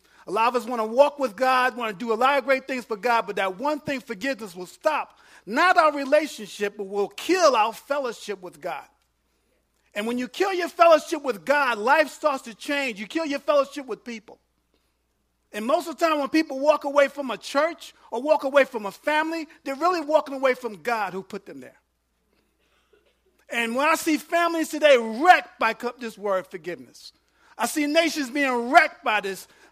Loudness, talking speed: -23 LUFS, 200 wpm